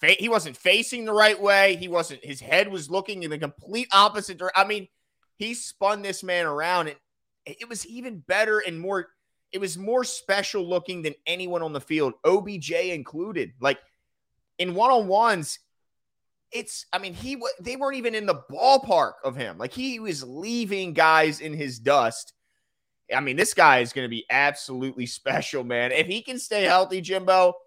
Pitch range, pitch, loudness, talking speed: 160-215 Hz, 190 Hz, -24 LUFS, 185 wpm